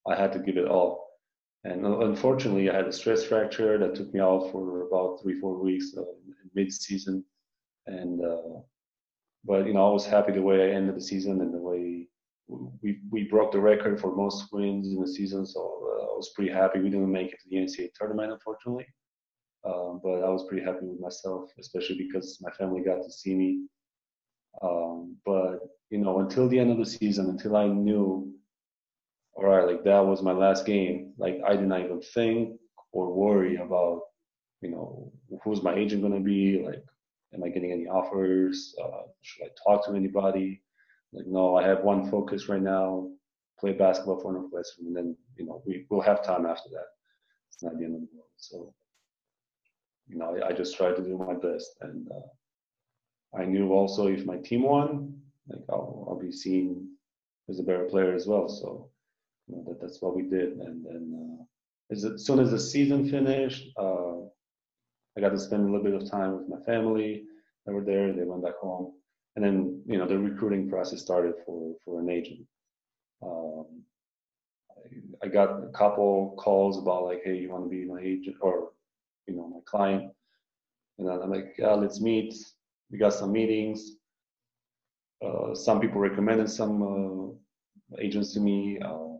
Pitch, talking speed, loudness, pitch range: 95 Hz, 190 wpm, -28 LUFS, 95-105 Hz